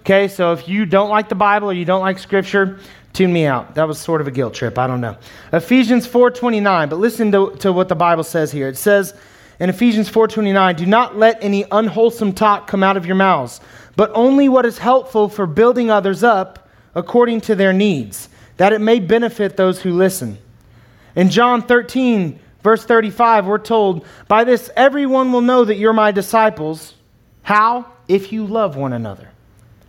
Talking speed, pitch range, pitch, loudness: 190 wpm, 175-225 Hz, 200 Hz, -15 LUFS